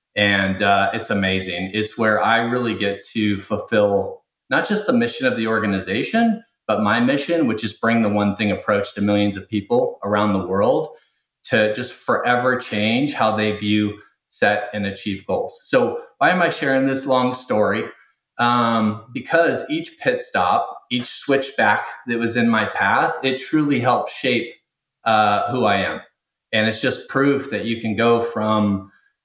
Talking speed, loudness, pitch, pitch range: 170 wpm, -20 LUFS, 110 Hz, 105-130 Hz